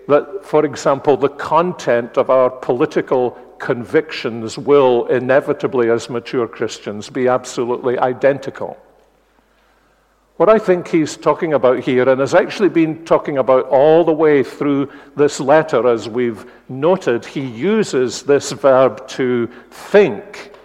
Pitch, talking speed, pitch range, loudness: 135 Hz, 130 wpm, 125-155 Hz, -16 LUFS